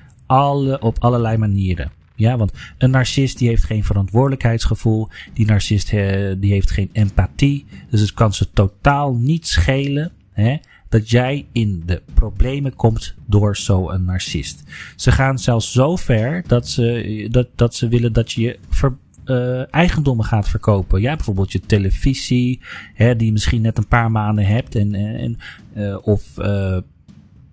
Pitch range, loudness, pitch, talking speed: 100-125 Hz, -18 LUFS, 110 Hz, 155 wpm